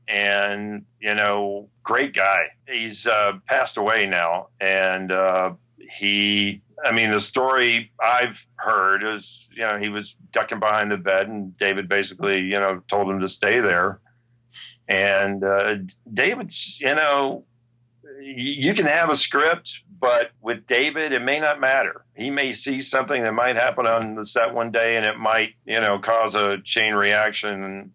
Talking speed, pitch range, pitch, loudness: 165 wpm, 100-120 Hz, 105 Hz, -21 LUFS